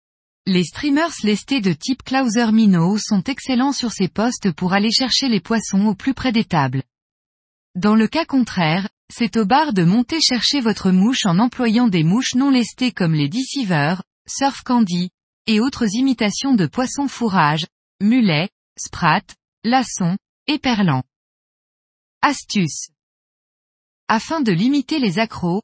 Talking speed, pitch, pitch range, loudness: 145 wpm, 220 Hz, 185-255 Hz, -18 LUFS